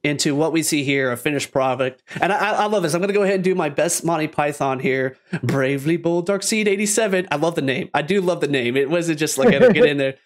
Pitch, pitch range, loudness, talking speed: 160 Hz, 140-195 Hz, -19 LUFS, 275 wpm